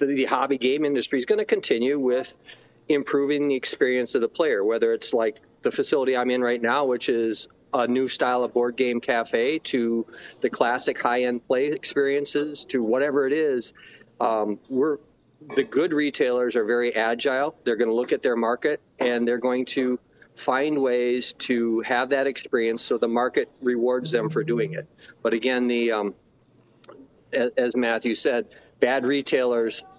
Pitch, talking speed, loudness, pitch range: 125 Hz, 170 wpm, -24 LUFS, 120-140 Hz